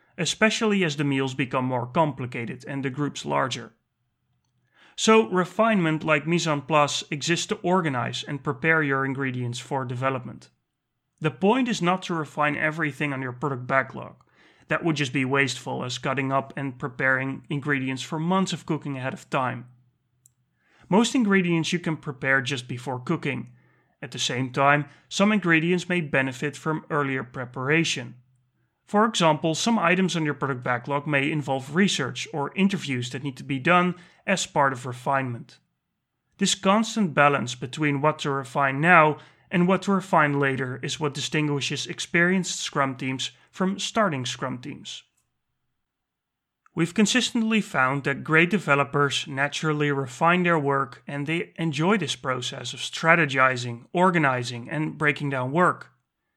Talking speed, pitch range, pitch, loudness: 150 wpm, 135-170 Hz, 145 Hz, -24 LUFS